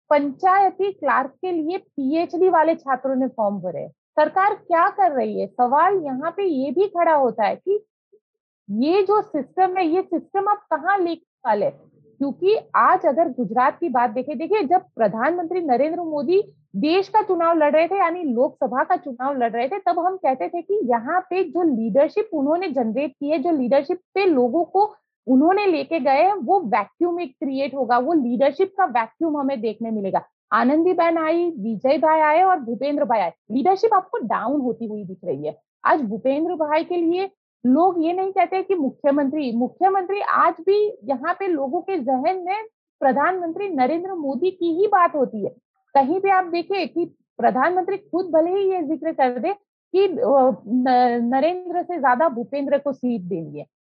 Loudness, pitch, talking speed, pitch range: -21 LUFS, 325 Hz, 175 wpm, 270-370 Hz